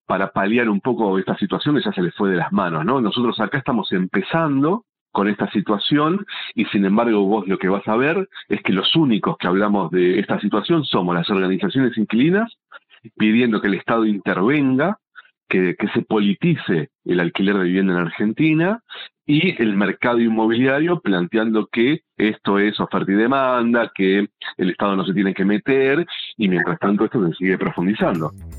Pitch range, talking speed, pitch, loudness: 95-130 Hz, 175 wpm, 105 Hz, -19 LUFS